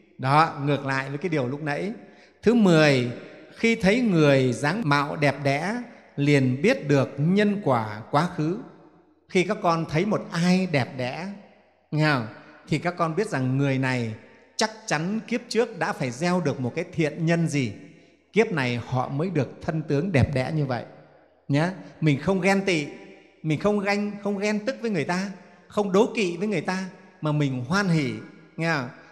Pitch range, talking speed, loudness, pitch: 140-195 Hz, 185 wpm, -24 LUFS, 160 Hz